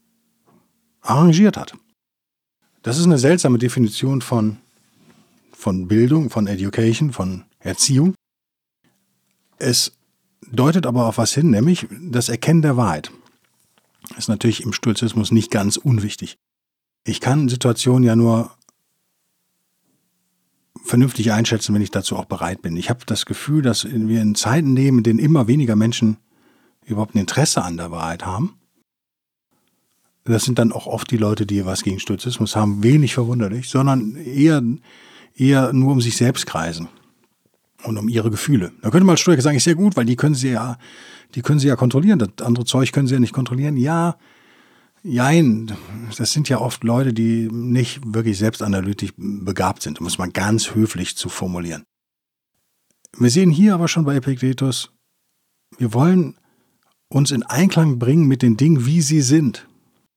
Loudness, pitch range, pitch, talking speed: -18 LUFS, 110-140 Hz, 120 Hz, 160 wpm